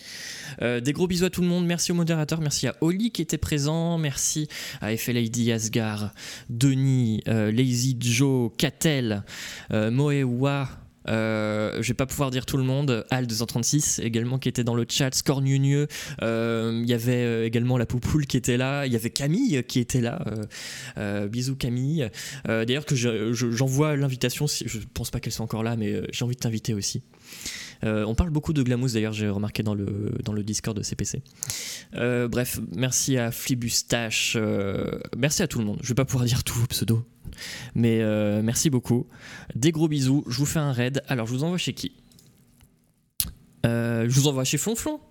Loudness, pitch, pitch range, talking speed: -25 LUFS, 125 Hz, 115-140 Hz, 195 wpm